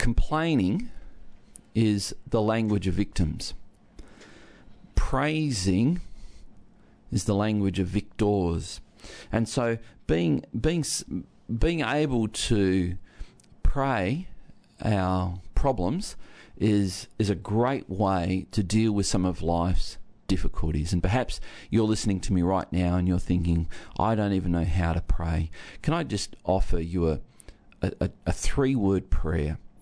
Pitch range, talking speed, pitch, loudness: 90-115 Hz, 125 wpm, 100 Hz, -27 LUFS